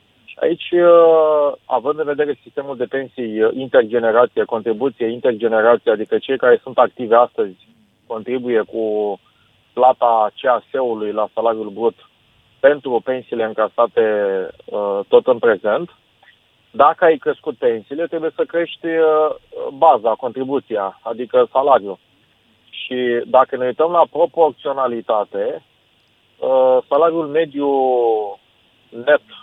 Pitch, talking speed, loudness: 145 Hz, 100 wpm, -17 LUFS